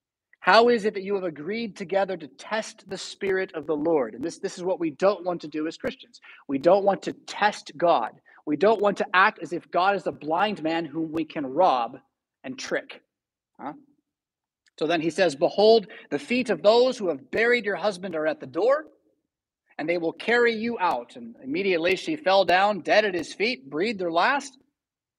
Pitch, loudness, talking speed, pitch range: 195 Hz, -24 LUFS, 210 wpm, 165-220 Hz